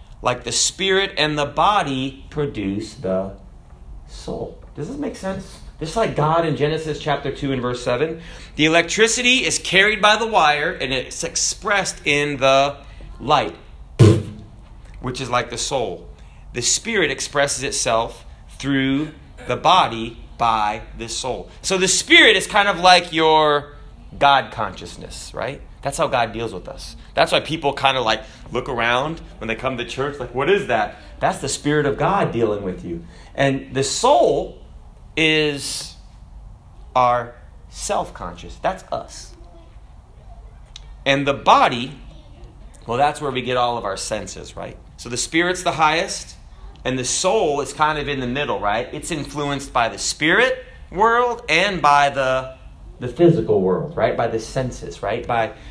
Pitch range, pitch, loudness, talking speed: 115-155 Hz, 135 Hz, -19 LUFS, 165 wpm